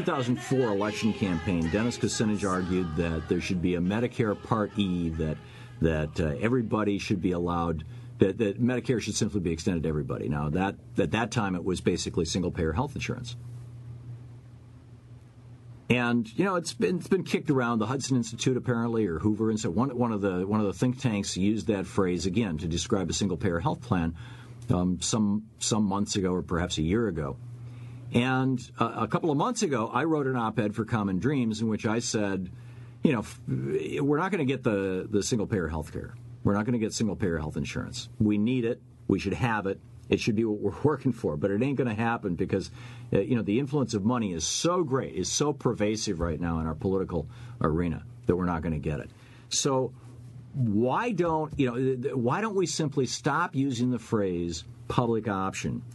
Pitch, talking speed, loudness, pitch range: 115 Hz, 205 wpm, -28 LUFS, 95-120 Hz